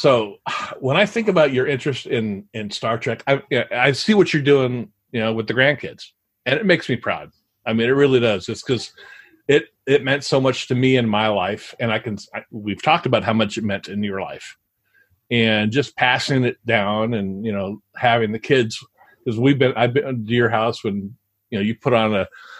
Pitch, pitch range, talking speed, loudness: 120 Hz, 110-140 Hz, 225 wpm, -20 LUFS